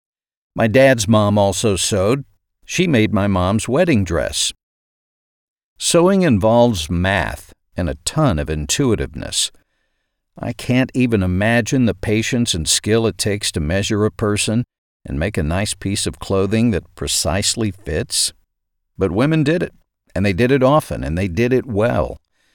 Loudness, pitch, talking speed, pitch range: -17 LUFS, 105 Hz, 150 wpm, 90-120 Hz